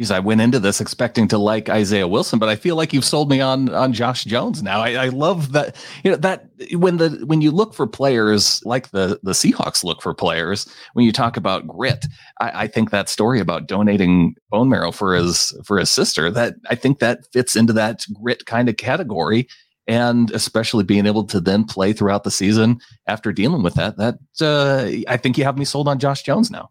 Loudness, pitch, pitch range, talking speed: -18 LUFS, 120 Hz, 105-135 Hz, 220 wpm